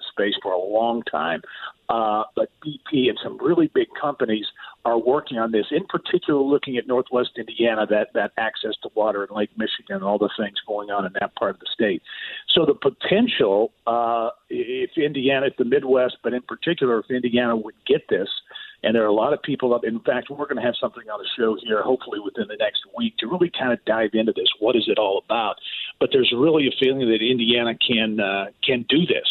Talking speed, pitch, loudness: 220 wpm, 125 Hz, -22 LUFS